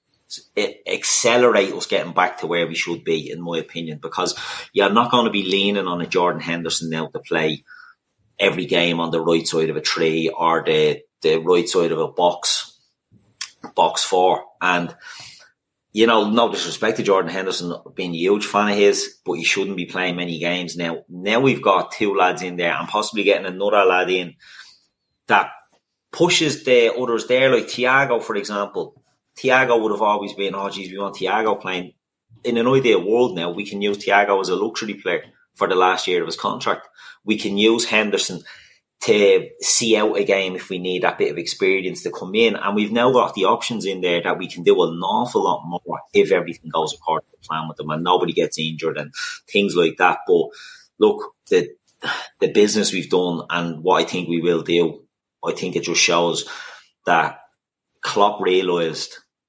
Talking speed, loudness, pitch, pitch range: 195 wpm, -19 LUFS, 100 Hz, 85-125 Hz